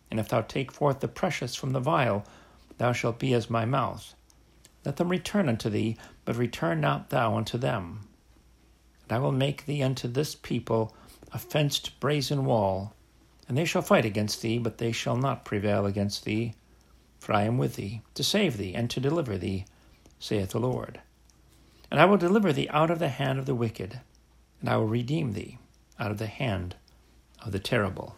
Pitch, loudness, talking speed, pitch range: 115 Hz, -28 LUFS, 195 wpm, 100-135 Hz